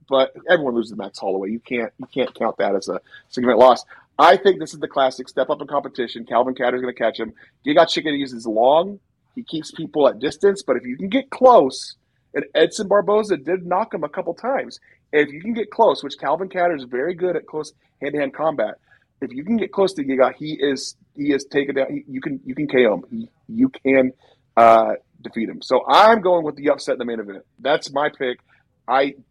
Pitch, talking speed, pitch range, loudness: 145 Hz, 225 wpm, 130-185 Hz, -19 LUFS